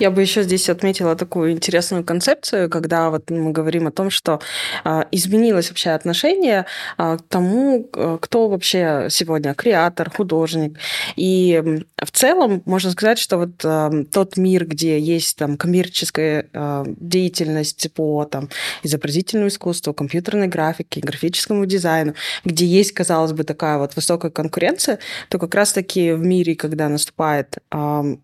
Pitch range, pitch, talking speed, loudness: 155-185 Hz, 170 Hz, 145 wpm, -18 LUFS